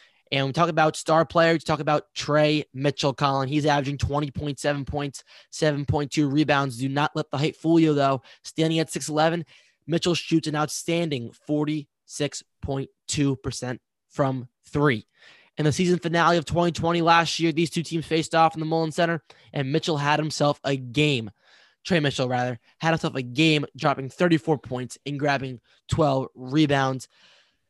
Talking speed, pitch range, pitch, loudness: 160 wpm, 140-160 Hz, 150 Hz, -24 LUFS